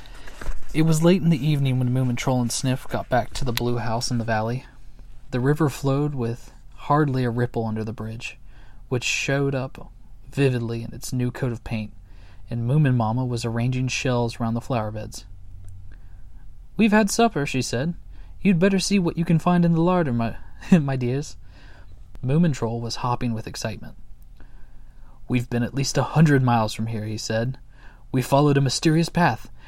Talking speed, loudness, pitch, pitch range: 180 wpm, -23 LUFS, 125 Hz, 110-140 Hz